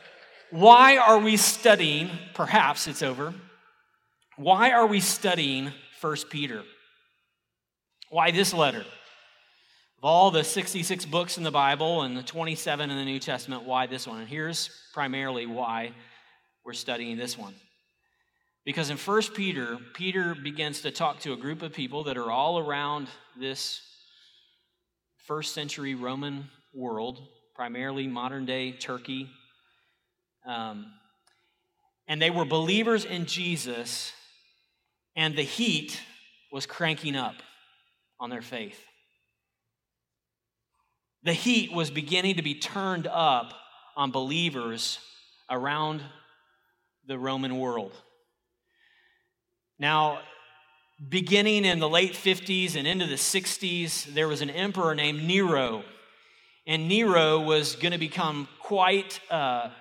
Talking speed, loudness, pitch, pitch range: 120 wpm, -26 LUFS, 155 Hz, 135-185 Hz